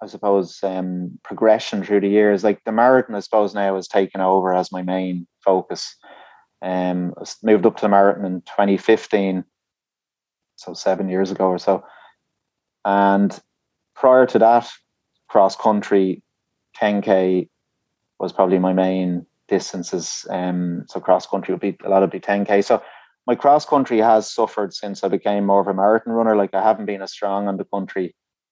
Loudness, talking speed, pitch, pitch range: -19 LUFS, 175 wpm, 100 Hz, 95-105 Hz